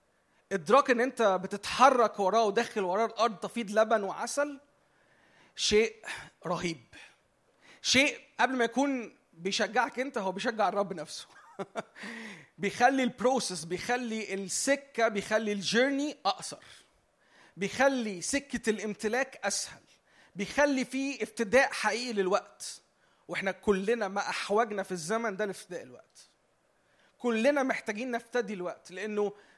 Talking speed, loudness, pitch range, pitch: 110 wpm, -30 LUFS, 200-250 Hz, 220 Hz